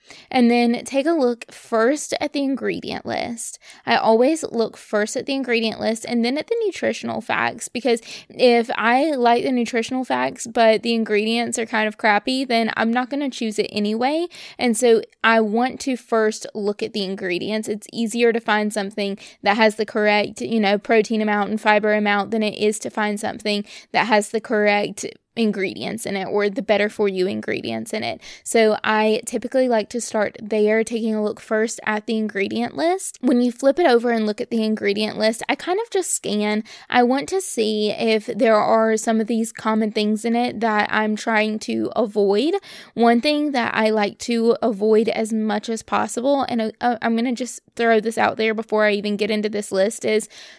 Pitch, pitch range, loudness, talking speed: 225 Hz, 210-240 Hz, -20 LUFS, 205 wpm